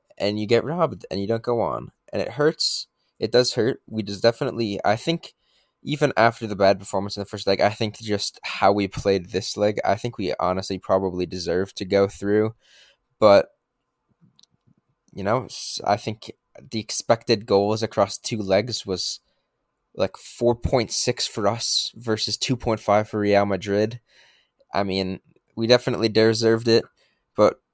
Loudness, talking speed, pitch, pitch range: -23 LUFS, 160 wpm, 105 Hz, 100-115 Hz